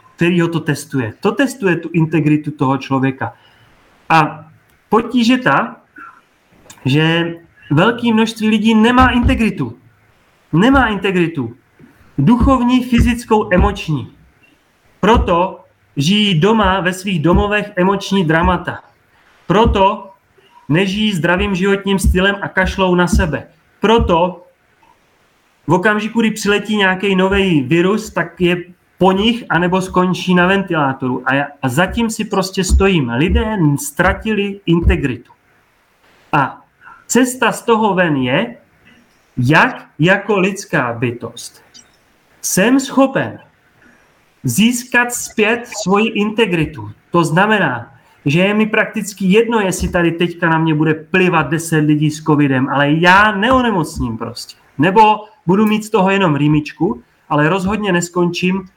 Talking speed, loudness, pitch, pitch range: 115 wpm, -14 LUFS, 185 Hz, 155-210 Hz